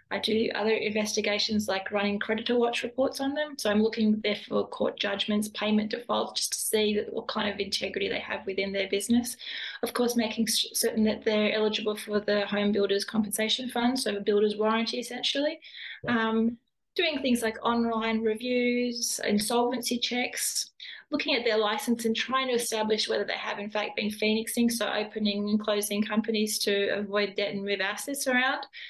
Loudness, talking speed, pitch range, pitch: -28 LUFS, 180 wpm, 210-240 Hz, 220 Hz